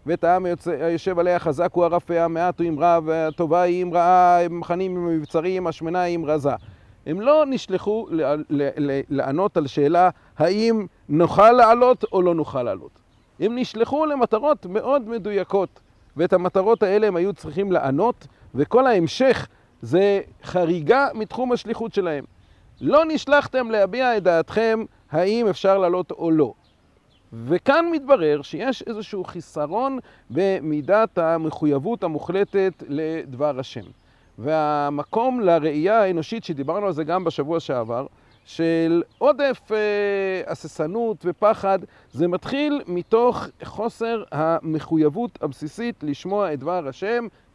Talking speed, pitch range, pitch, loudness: 130 wpm, 160-220 Hz, 180 Hz, -21 LUFS